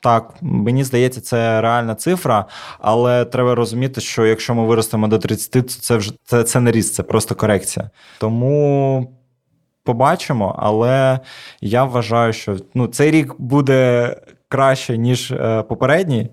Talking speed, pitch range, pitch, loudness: 140 wpm, 115-130 Hz, 120 Hz, -17 LUFS